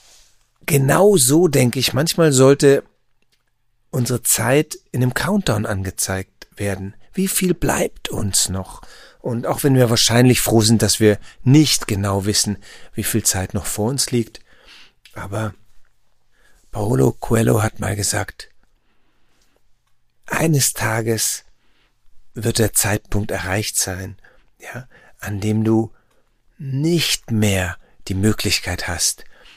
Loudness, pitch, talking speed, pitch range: -18 LUFS, 110 Hz, 120 wpm, 105-130 Hz